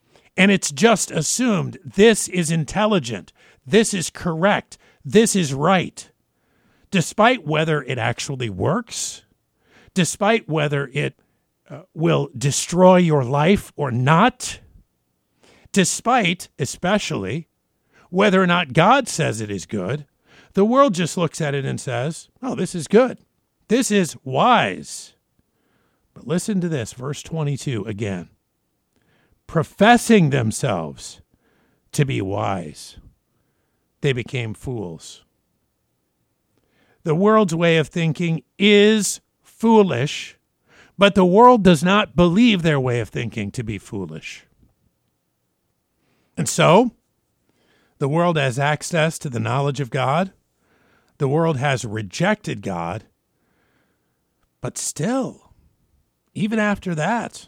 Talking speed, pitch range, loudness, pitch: 115 wpm, 140-200 Hz, -19 LUFS, 165 Hz